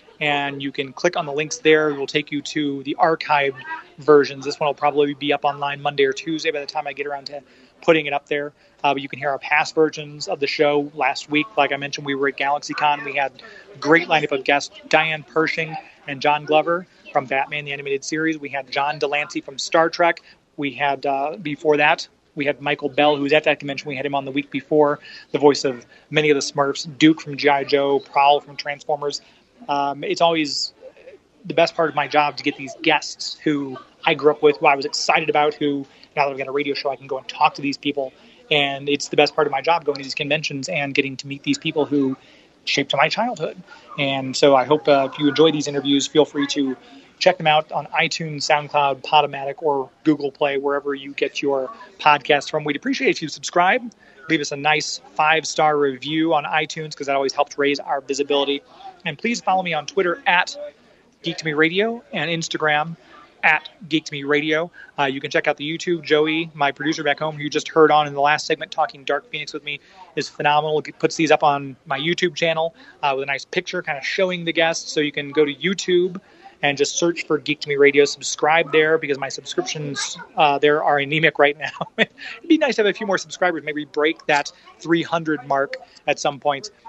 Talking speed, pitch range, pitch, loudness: 230 wpm, 140-160 Hz, 150 Hz, -20 LUFS